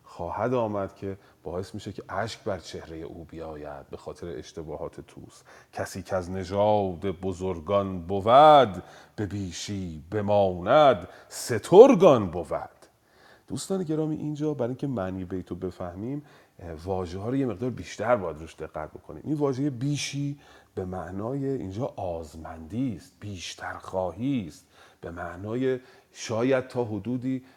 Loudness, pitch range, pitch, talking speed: -26 LUFS, 90-130 Hz, 100 Hz, 135 wpm